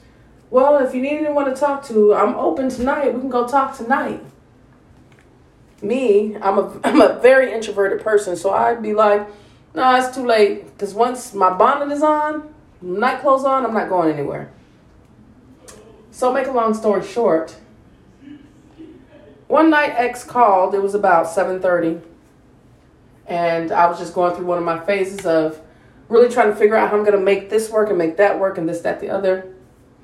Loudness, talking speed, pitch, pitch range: -17 LUFS, 185 wpm, 215 Hz, 190-255 Hz